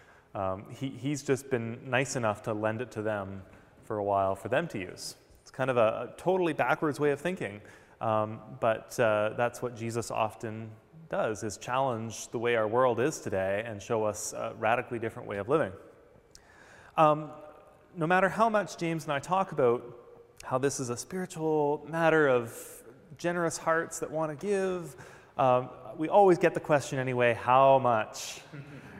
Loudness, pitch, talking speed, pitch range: -29 LUFS, 135 Hz, 180 wpm, 115-160 Hz